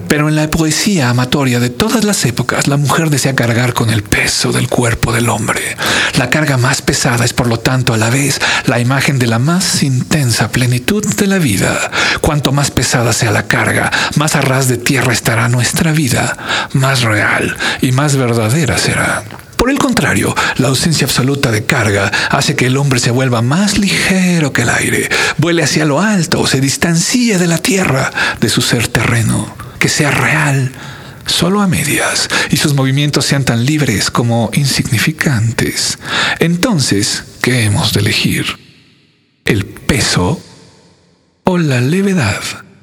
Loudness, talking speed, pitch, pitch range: -12 LUFS, 165 wpm, 135 Hz, 120-155 Hz